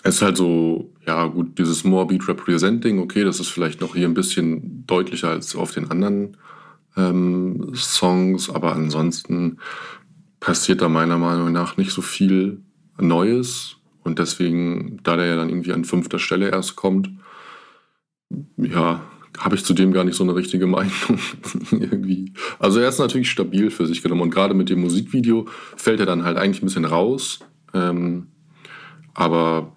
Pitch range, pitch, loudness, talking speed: 85-95 Hz, 90 Hz, -20 LUFS, 165 wpm